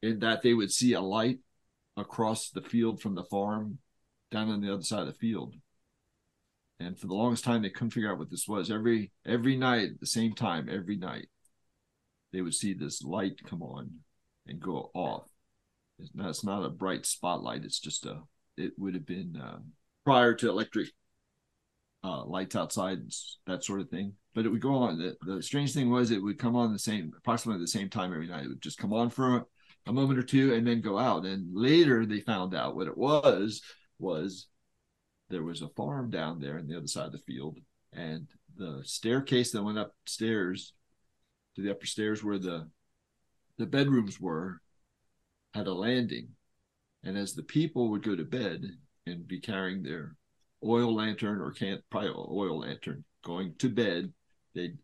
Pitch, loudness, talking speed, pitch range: 110 Hz, -31 LUFS, 195 wpm, 95-120 Hz